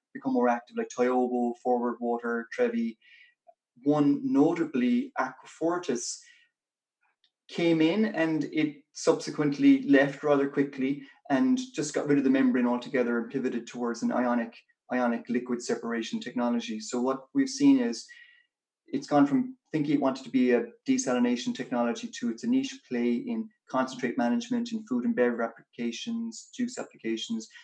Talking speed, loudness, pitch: 145 wpm, -28 LUFS, 145 Hz